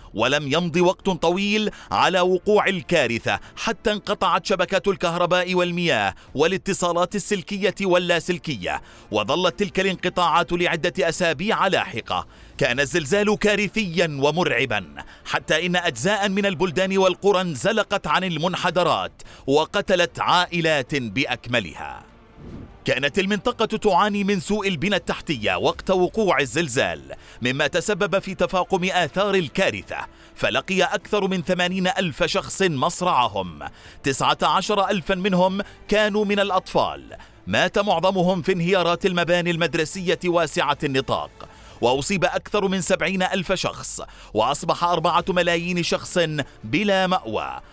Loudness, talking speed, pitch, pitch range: -21 LUFS, 110 wpm, 180 Hz, 170-195 Hz